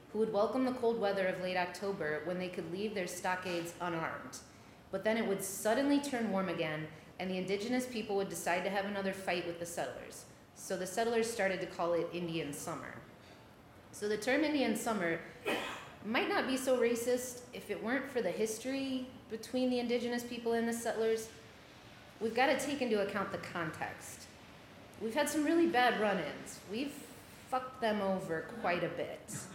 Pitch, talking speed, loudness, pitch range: 210 Hz, 185 wpm, -35 LUFS, 180-245 Hz